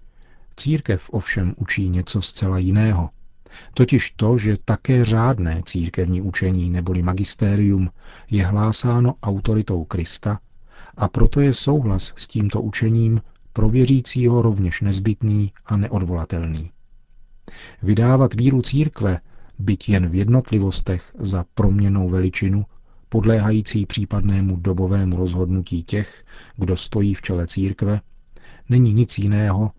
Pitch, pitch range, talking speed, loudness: 100 Hz, 95-115 Hz, 110 wpm, -20 LUFS